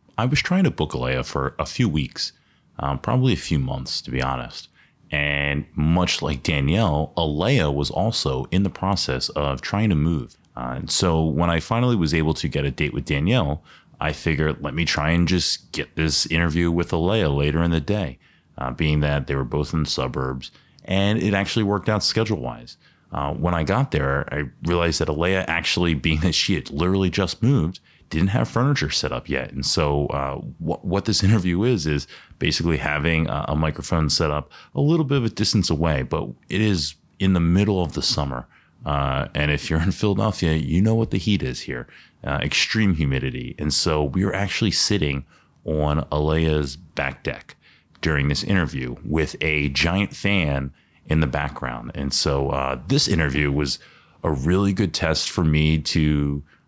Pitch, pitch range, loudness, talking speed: 80 Hz, 70-95 Hz, -22 LUFS, 195 wpm